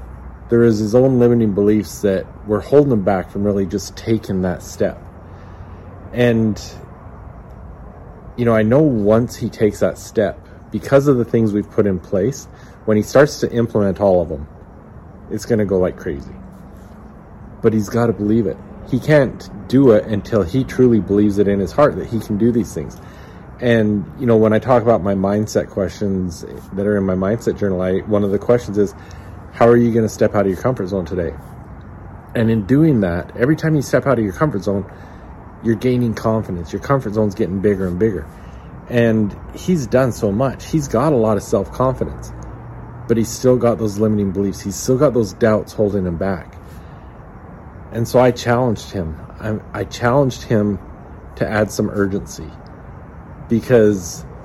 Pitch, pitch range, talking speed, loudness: 105 Hz, 95-115 Hz, 185 wpm, -17 LUFS